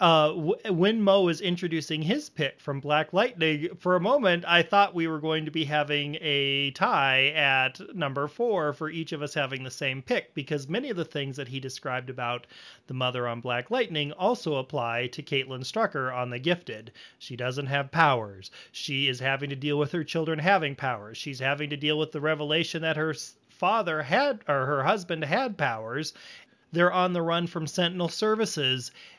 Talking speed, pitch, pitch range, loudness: 190 wpm, 150 Hz, 135-170 Hz, -27 LUFS